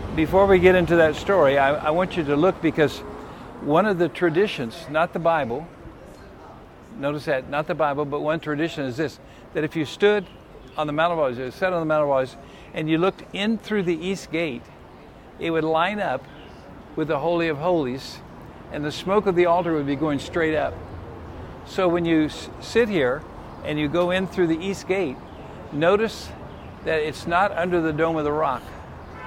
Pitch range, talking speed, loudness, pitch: 150-180 Hz, 190 wpm, -23 LUFS, 160 Hz